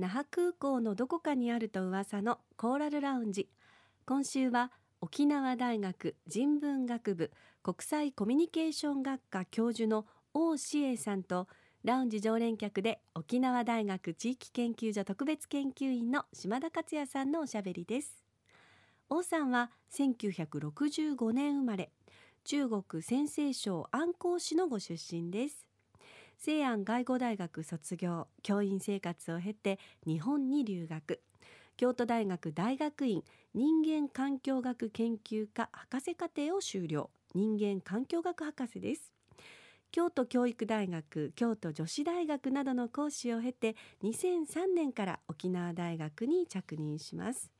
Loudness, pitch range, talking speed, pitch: -35 LUFS, 195-285 Hz, 250 characters per minute, 240 Hz